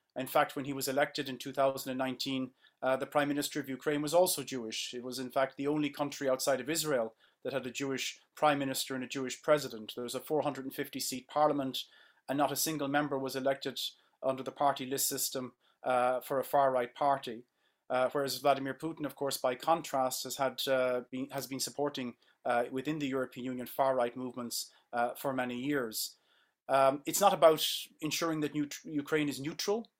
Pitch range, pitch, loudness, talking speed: 130-145 Hz, 135 Hz, -33 LUFS, 200 wpm